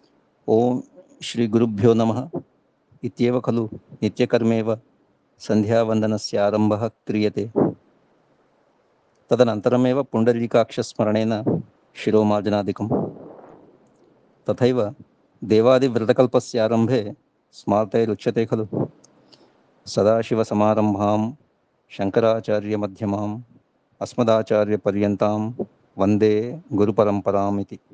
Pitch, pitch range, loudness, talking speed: 110 Hz, 105-120 Hz, -21 LUFS, 45 wpm